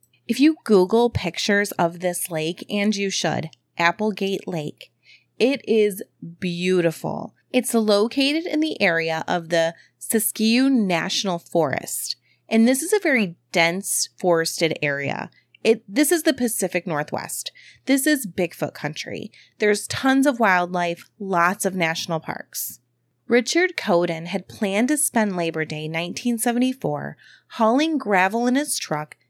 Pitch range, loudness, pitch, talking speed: 170-245 Hz, -22 LUFS, 200 Hz, 135 wpm